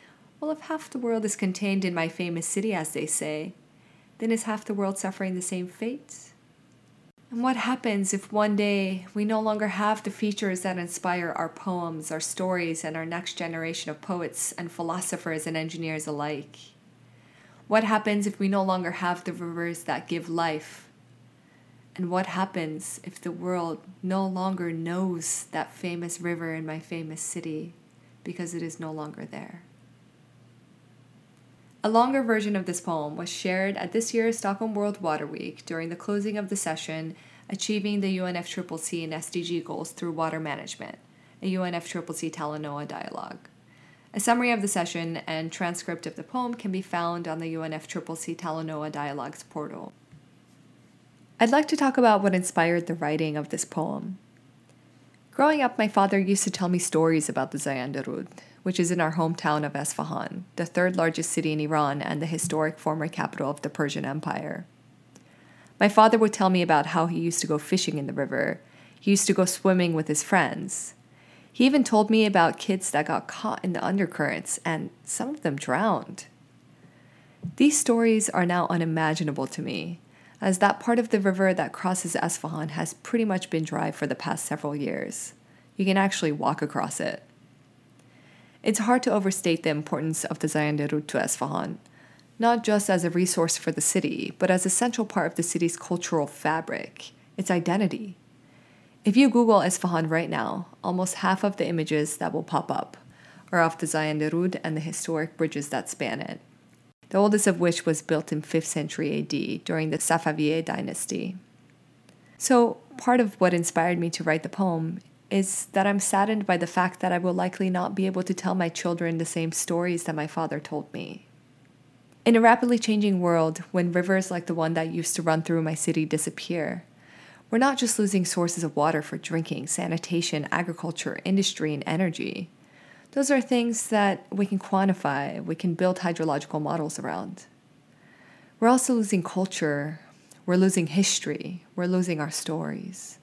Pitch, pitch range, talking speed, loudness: 175 Hz, 160-195 Hz, 175 wpm, -26 LUFS